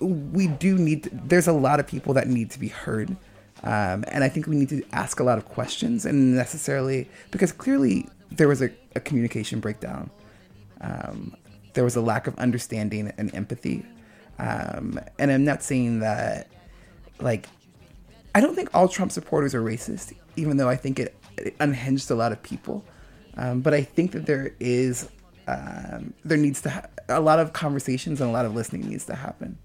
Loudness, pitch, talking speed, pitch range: -25 LUFS, 135 Hz, 190 wpm, 120-155 Hz